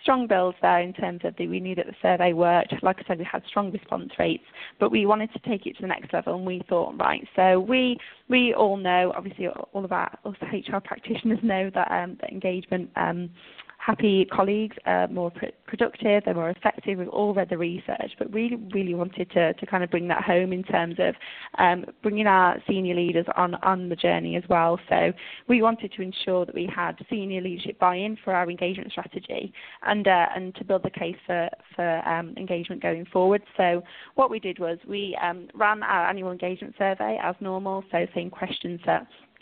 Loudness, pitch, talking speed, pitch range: -25 LUFS, 185 Hz, 210 wpm, 175-205 Hz